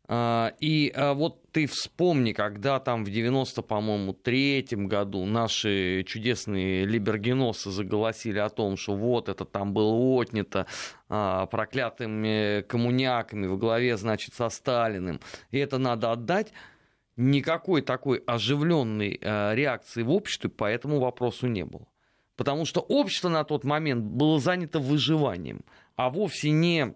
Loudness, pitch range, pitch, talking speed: -27 LUFS, 105-140 Hz, 120 Hz, 125 wpm